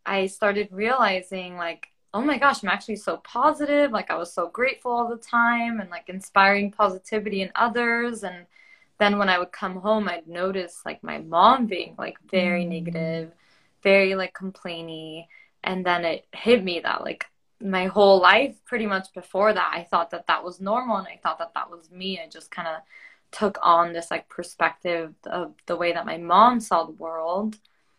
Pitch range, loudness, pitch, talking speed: 175-215 Hz, -23 LUFS, 190 Hz, 190 wpm